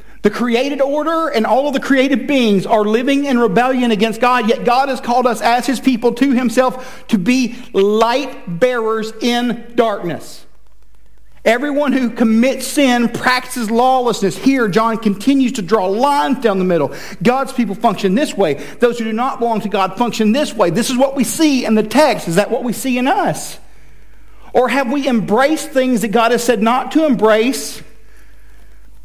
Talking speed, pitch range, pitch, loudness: 180 wpm, 220-260 Hz, 240 Hz, -15 LUFS